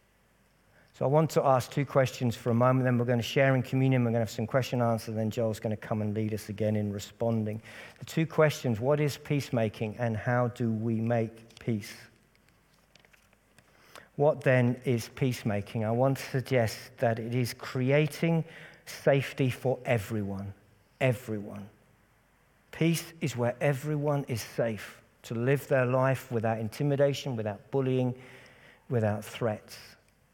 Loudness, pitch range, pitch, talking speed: -29 LUFS, 115-135 Hz, 125 Hz, 160 wpm